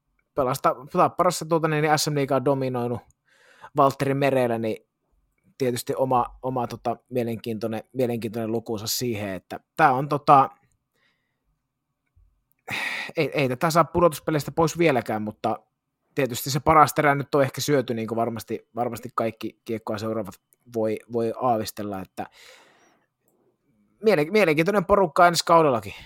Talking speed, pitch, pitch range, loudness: 120 wpm, 125 Hz, 115-145 Hz, -23 LUFS